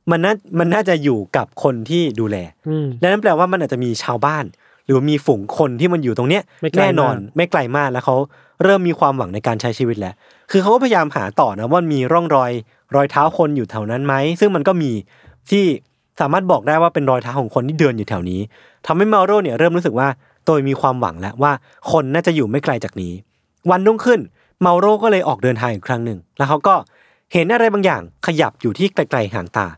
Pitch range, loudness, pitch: 125-175 Hz, -17 LUFS, 145 Hz